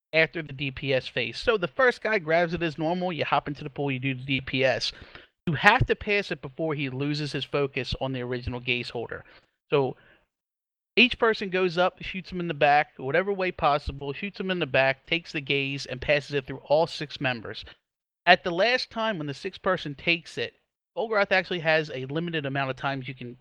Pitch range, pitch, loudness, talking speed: 135-180 Hz, 155 Hz, -26 LUFS, 215 wpm